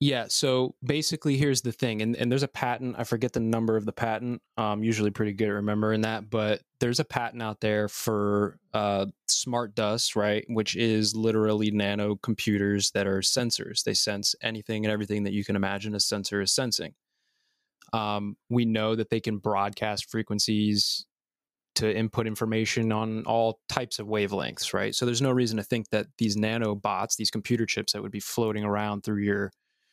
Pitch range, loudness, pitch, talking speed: 105-115 Hz, -27 LUFS, 110 Hz, 190 wpm